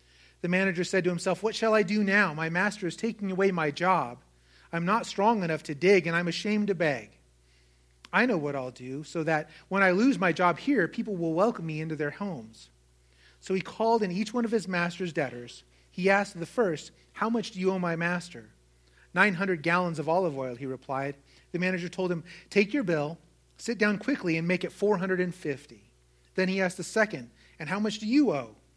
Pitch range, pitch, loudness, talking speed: 150-200 Hz, 175 Hz, -28 LUFS, 210 wpm